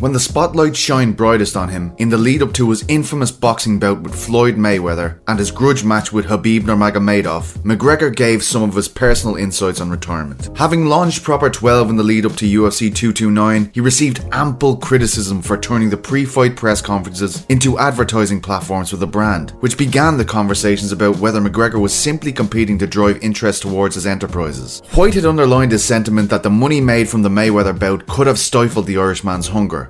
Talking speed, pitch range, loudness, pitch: 190 wpm, 100-125 Hz, -15 LUFS, 110 Hz